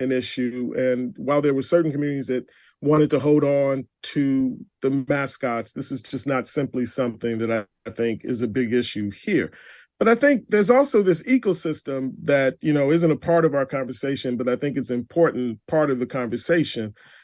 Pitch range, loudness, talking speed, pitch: 125-155 Hz, -22 LUFS, 190 wpm, 135 Hz